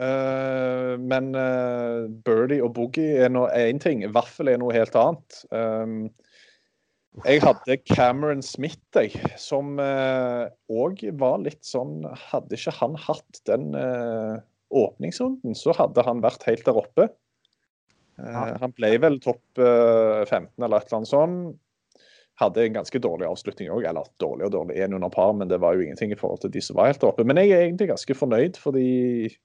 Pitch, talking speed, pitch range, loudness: 125 Hz, 175 wpm, 115-140 Hz, -23 LUFS